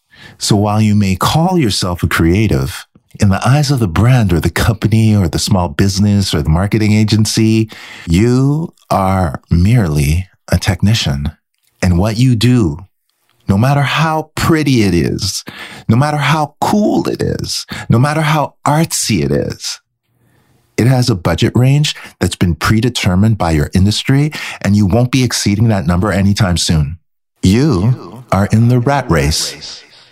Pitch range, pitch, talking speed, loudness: 95-125 Hz, 110 Hz, 155 wpm, -13 LUFS